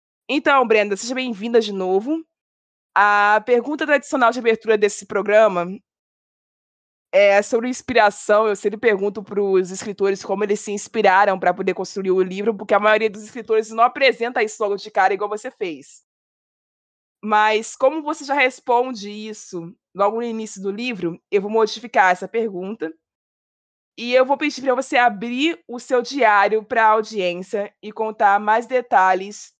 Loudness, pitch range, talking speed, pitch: -19 LUFS, 200-240 Hz, 160 wpm, 215 Hz